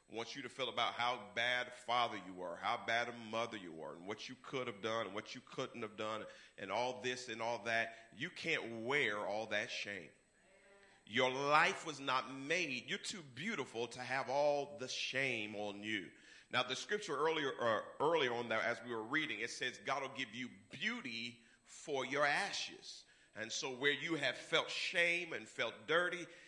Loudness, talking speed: -39 LUFS, 200 wpm